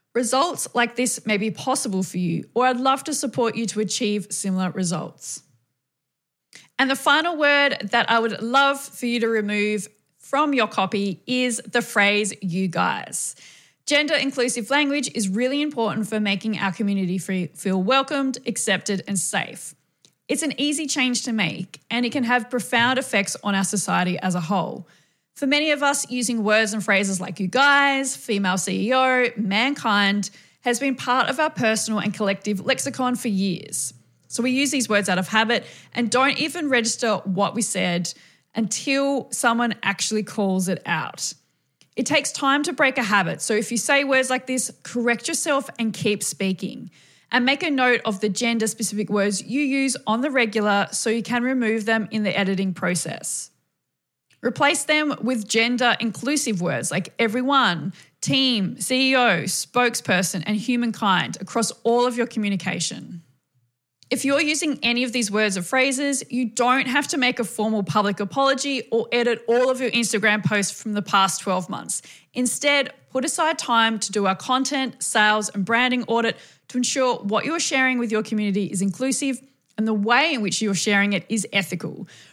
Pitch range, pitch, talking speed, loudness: 200-255 Hz, 225 Hz, 175 wpm, -22 LUFS